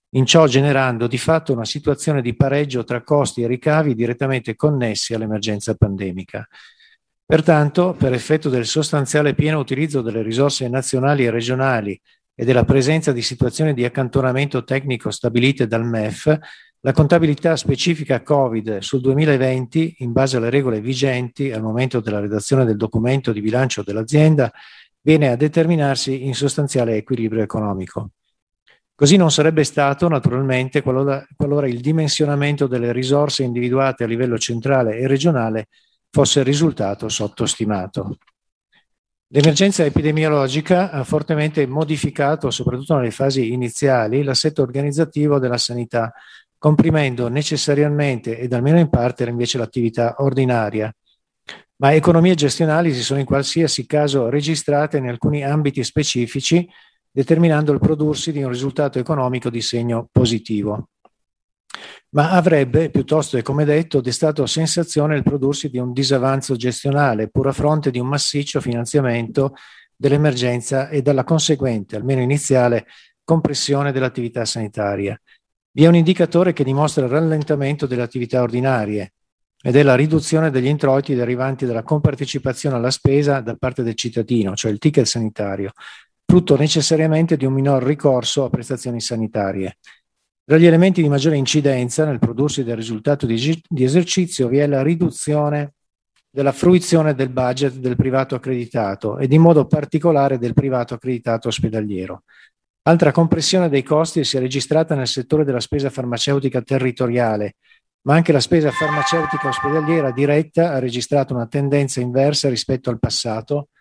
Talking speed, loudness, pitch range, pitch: 135 wpm, -18 LUFS, 120-150 Hz, 135 Hz